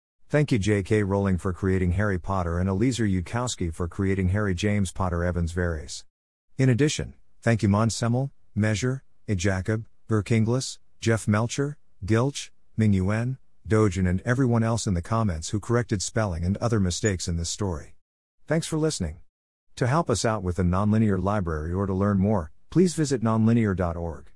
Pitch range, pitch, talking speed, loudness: 90-115 Hz, 105 Hz, 165 wpm, -25 LUFS